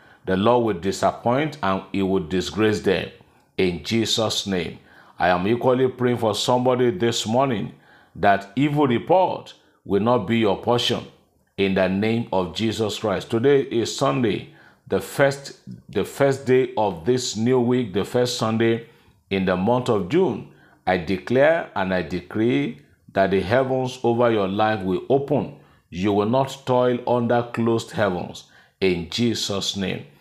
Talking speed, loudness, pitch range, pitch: 155 wpm, -22 LUFS, 100-125 Hz, 115 Hz